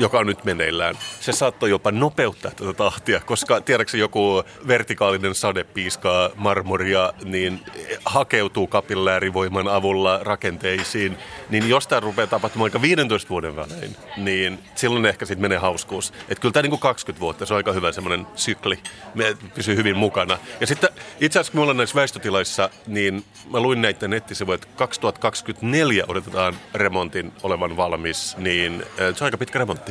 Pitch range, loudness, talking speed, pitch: 95-115 Hz, -21 LUFS, 160 wpm, 100 Hz